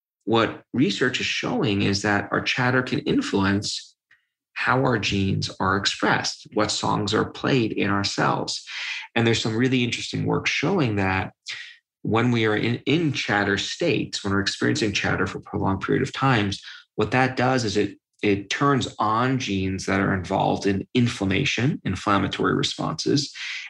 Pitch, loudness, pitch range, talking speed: 110 Hz, -23 LUFS, 100-130 Hz, 160 wpm